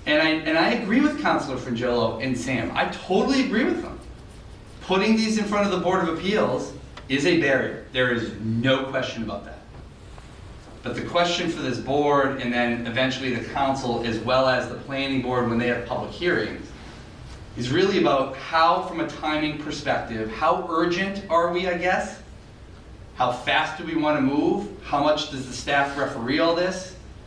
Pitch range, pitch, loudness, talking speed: 120-185 Hz, 140 Hz, -23 LUFS, 185 wpm